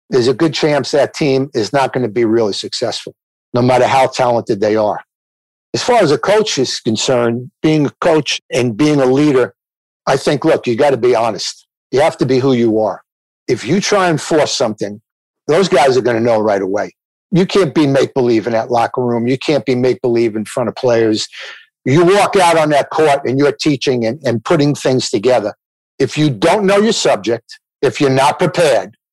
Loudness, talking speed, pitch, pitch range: -14 LUFS, 215 wpm, 130 Hz, 115-155 Hz